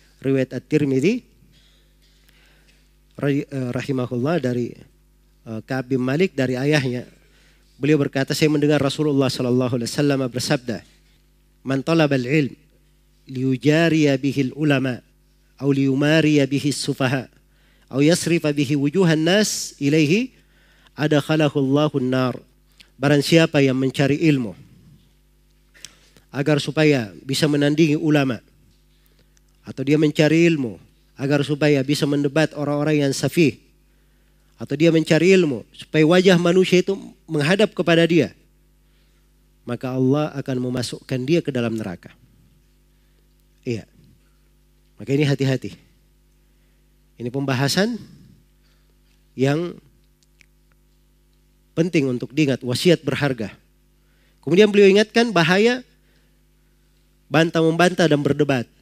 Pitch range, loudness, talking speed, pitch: 130-155 Hz, -19 LUFS, 105 wpm, 140 Hz